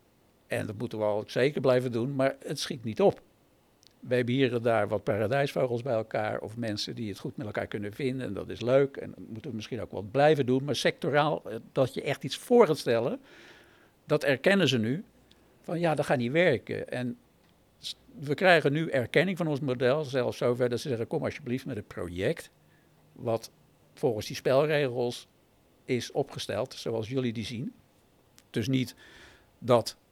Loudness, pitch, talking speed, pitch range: -29 LUFS, 125 Hz, 185 wpm, 115-140 Hz